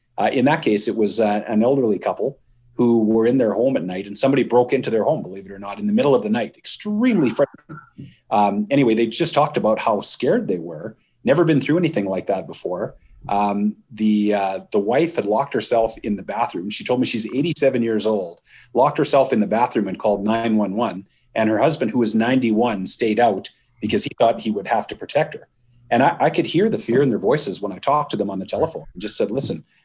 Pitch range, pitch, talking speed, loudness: 105-135 Hz, 115 Hz, 235 wpm, -20 LUFS